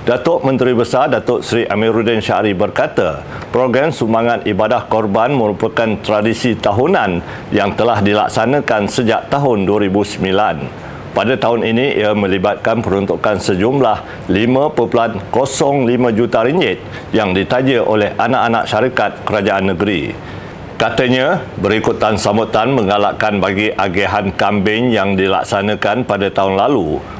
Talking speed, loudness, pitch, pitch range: 110 wpm, -14 LUFS, 105 Hz, 100-120 Hz